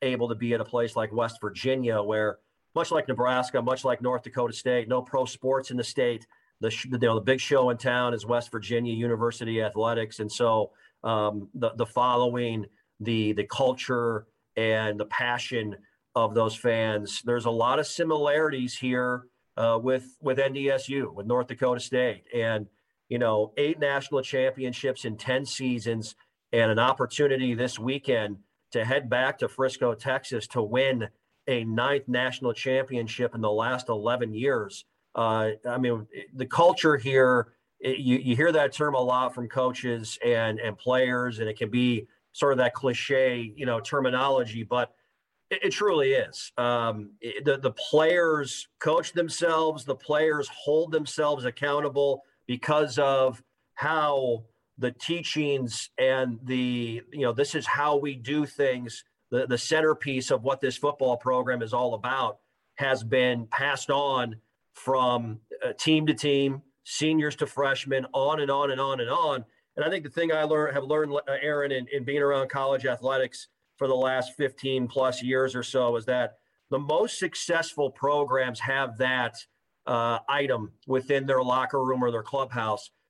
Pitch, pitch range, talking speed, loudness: 125 Hz, 120-140 Hz, 165 wpm, -27 LUFS